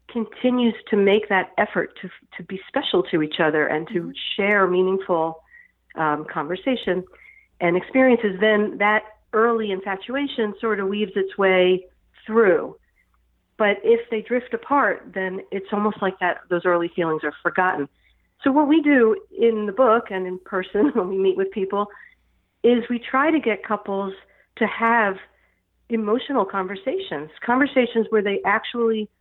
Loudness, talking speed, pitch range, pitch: -21 LUFS, 150 wpm, 185-230 Hz, 205 Hz